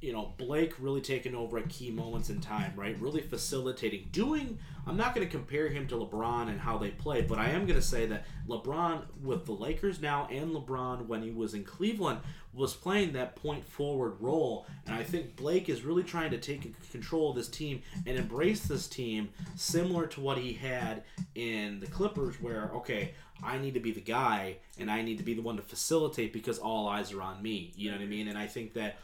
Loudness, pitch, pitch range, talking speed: -35 LUFS, 135 Hz, 115-160 Hz, 225 wpm